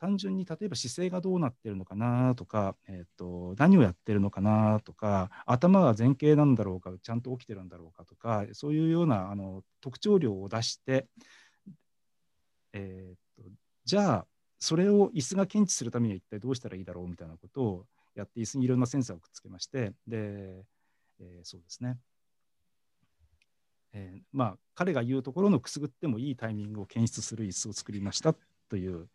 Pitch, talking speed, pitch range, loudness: 110 Hz, 380 characters per minute, 95-135 Hz, -29 LUFS